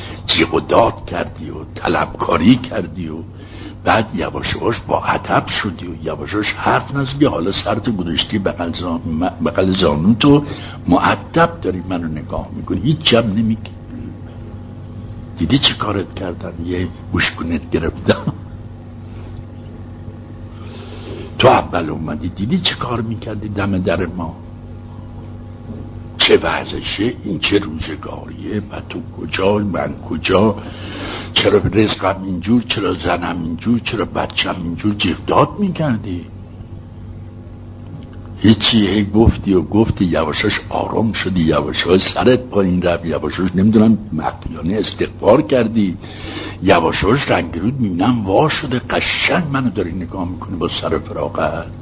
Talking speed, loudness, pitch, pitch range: 115 wpm, -16 LUFS, 105 Hz, 90-110 Hz